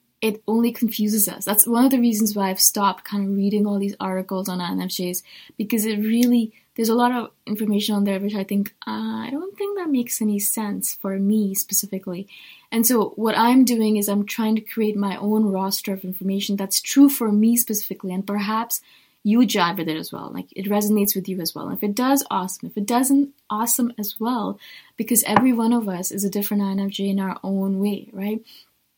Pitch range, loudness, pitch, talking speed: 195-230 Hz, -21 LUFS, 210 Hz, 215 wpm